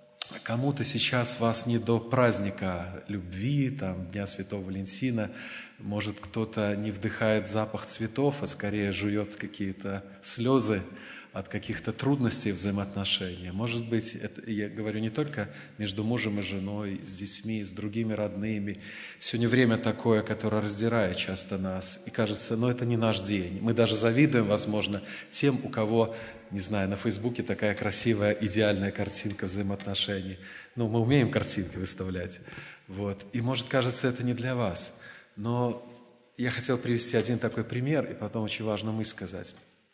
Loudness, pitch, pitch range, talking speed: -29 LUFS, 110 Hz, 100-115 Hz, 145 wpm